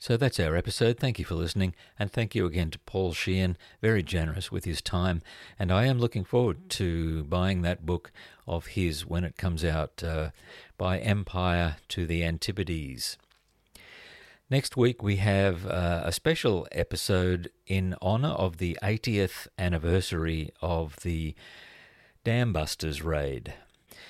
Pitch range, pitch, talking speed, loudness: 85-100 Hz, 90 Hz, 145 wpm, -29 LUFS